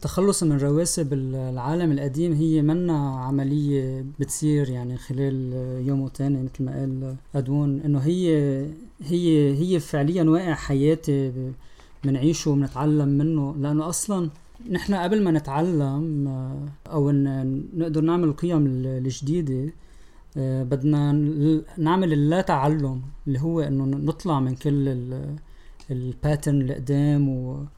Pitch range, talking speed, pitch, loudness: 135-160 Hz, 110 wpm, 145 Hz, -24 LUFS